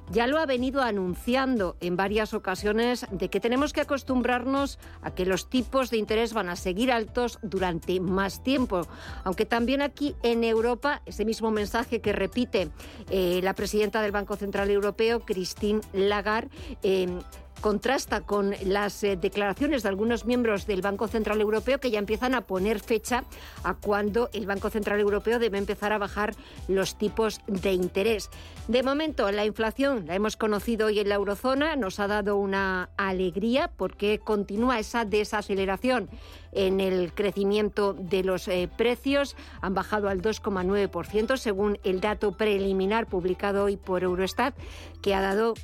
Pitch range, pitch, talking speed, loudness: 195-235 Hz, 210 Hz, 155 wpm, -27 LUFS